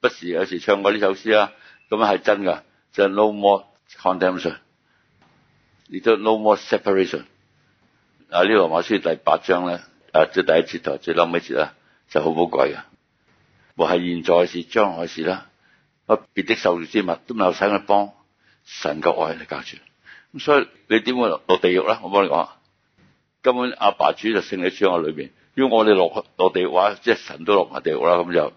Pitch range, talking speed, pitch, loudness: 90-110 Hz, 330 characters per minute, 100 Hz, -20 LUFS